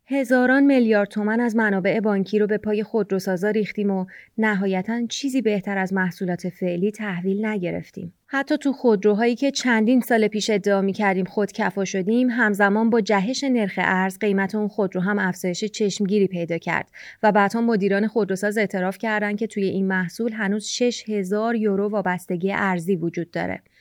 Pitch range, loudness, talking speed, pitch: 195-225 Hz, -22 LUFS, 160 wpm, 210 Hz